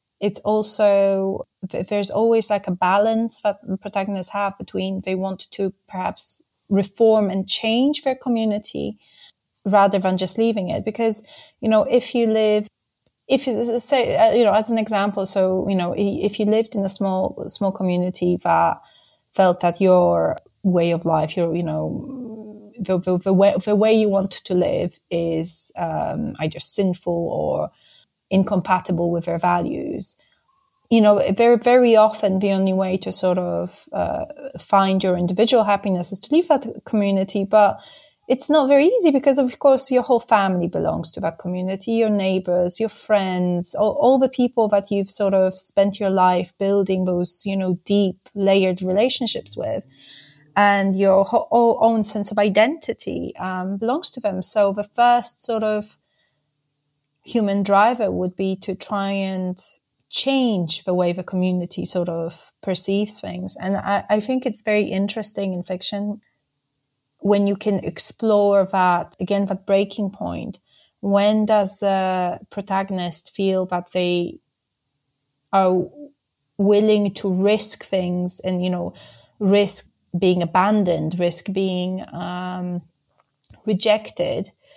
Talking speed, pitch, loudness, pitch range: 150 wpm, 195 Hz, -19 LUFS, 180-215 Hz